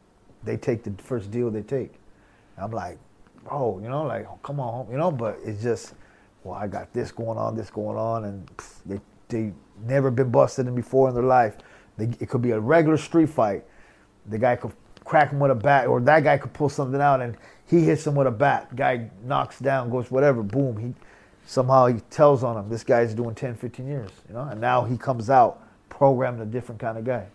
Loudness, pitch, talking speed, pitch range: -23 LUFS, 125 Hz, 225 wpm, 110-135 Hz